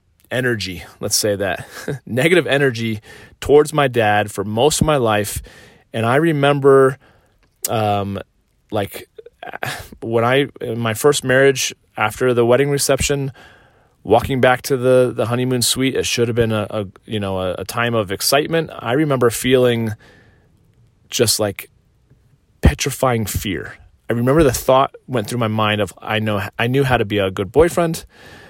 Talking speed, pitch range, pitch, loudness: 160 wpm, 105-135 Hz, 120 Hz, -17 LUFS